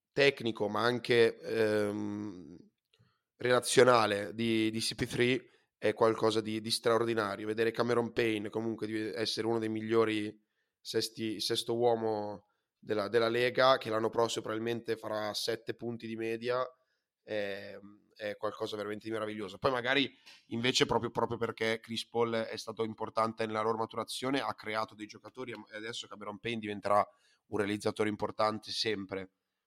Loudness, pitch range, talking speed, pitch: -32 LUFS, 105-115 Hz, 140 wpm, 110 Hz